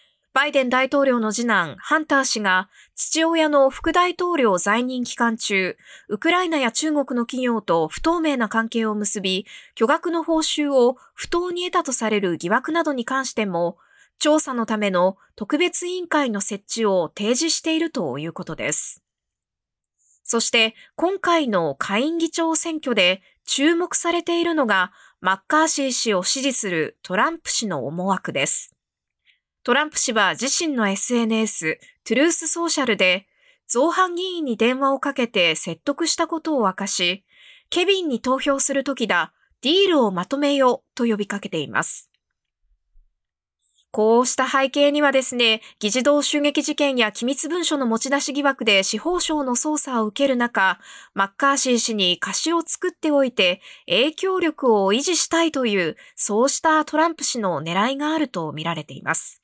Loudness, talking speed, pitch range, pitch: -19 LUFS, 315 characters per minute, 205-315 Hz, 260 Hz